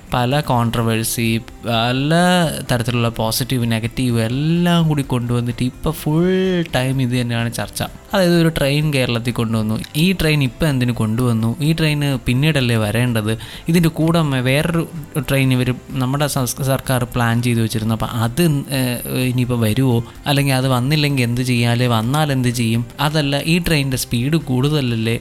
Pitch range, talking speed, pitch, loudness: 120-150 Hz, 130 wpm, 130 Hz, -18 LUFS